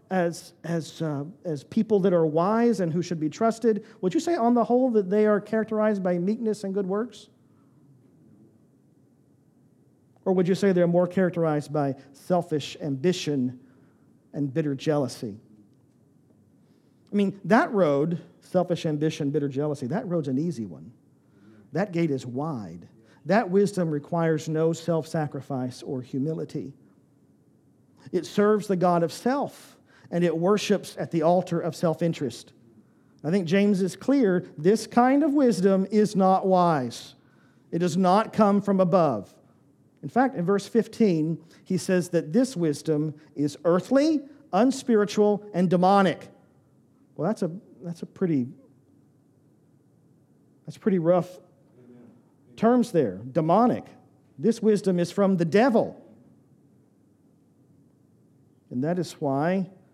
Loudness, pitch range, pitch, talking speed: -25 LUFS, 145-200 Hz, 175 Hz, 135 wpm